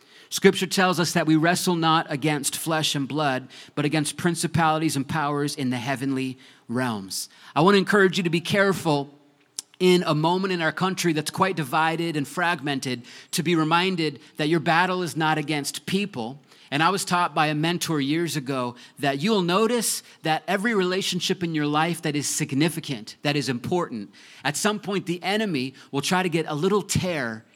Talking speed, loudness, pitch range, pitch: 185 wpm, -24 LUFS, 145-180 Hz, 160 Hz